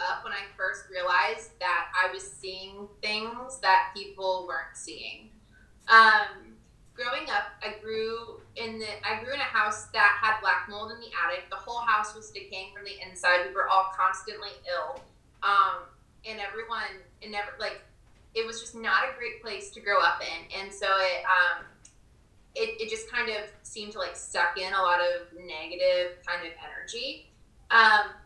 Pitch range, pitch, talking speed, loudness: 185-220 Hz, 200 Hz, 180 wpm, -27 LUFS